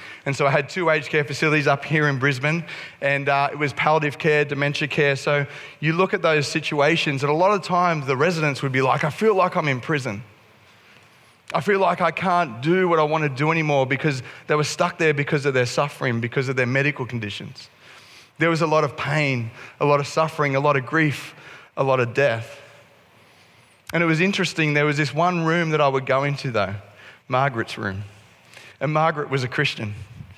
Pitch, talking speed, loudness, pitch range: 145 Hz, 215 wpm, -21 LUFS, 135-160 Hz